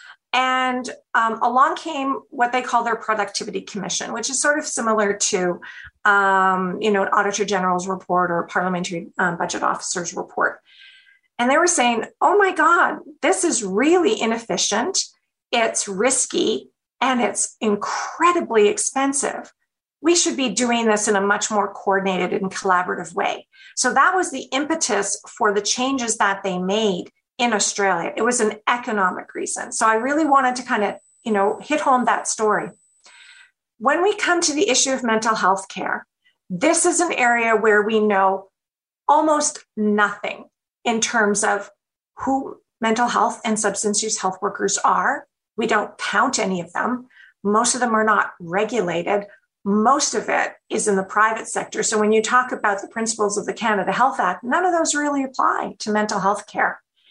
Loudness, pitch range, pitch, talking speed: -20 LUFS, 205-275 Hz, 225 Hz, 170 wpm